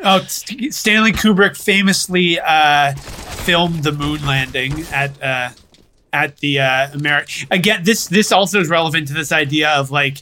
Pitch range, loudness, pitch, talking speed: 145-195 Hz, -15 LUFS, 155 Hz, 155 wpm